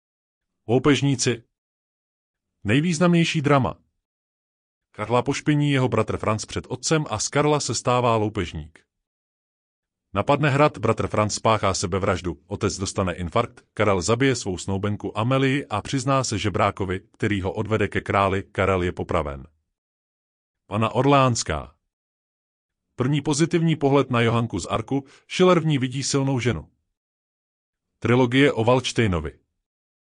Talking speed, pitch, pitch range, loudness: 120 wpm, 110 Hz, 95-135 Hz, -22 LUFS